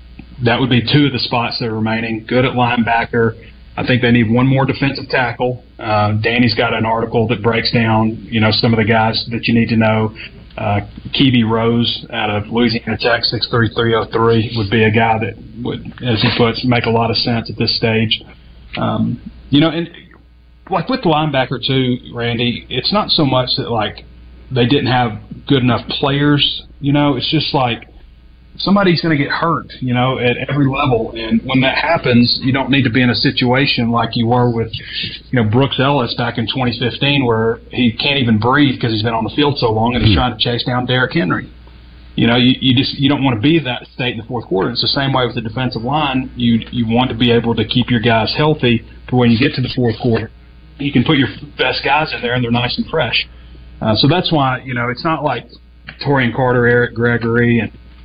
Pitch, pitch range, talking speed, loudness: 120 Hz, 115-130 Hz, 230 wpm, -15 LUFS